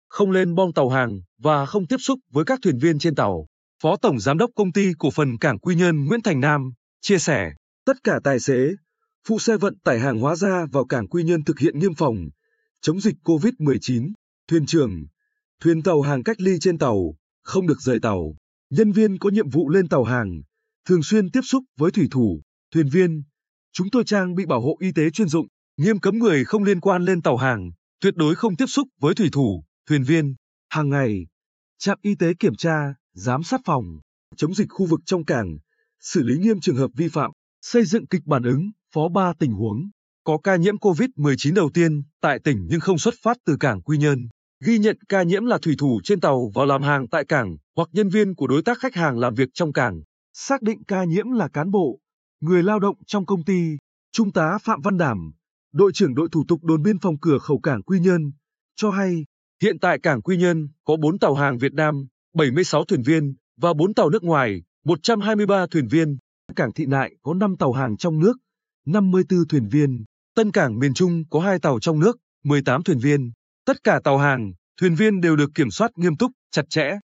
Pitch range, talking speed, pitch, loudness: 140-200 Hz, 215 wpm, 165 Hz, -21 LUFS